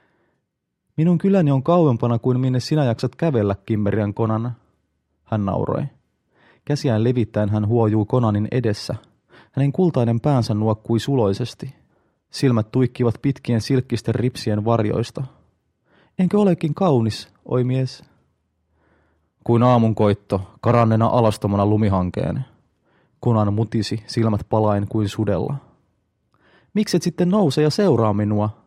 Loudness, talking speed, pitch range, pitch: -20 LUFS, 110 wpm, 105-135 Hz, 115 Hz